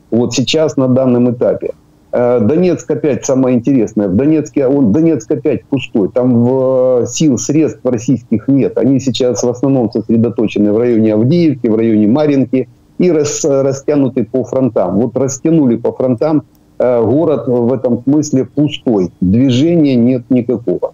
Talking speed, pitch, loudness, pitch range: 140 wpm, 130 Hz, -12 LUFS, 120-145 Hz